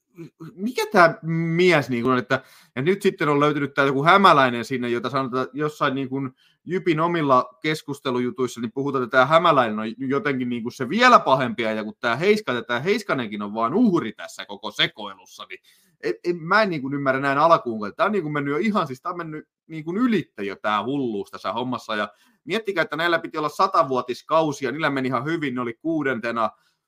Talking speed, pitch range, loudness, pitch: 190 wpm, 125-165 Hz, -22 LUFS, 140 Hz